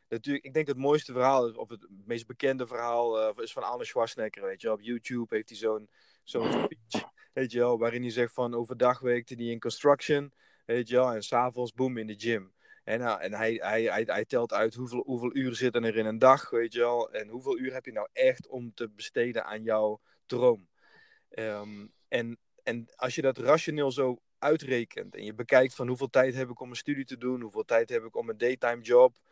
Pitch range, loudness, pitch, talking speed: 115-135 Hz, -29 LUFS, 125 Hz, 225 wpm